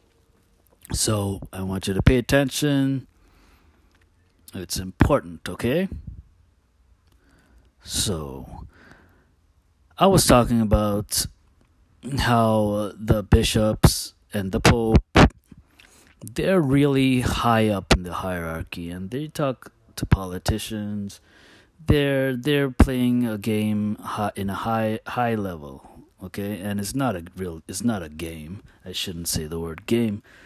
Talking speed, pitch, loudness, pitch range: 115 wpm, 100 Hz, -23 LUFS, 85-115 Hz